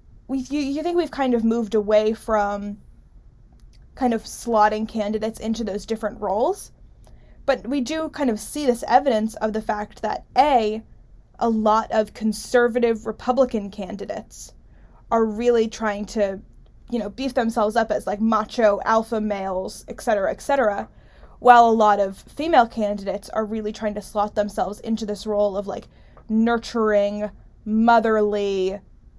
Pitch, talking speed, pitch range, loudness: 220 Hz, 150 wpm, 210-235 Hz, -22 LUFS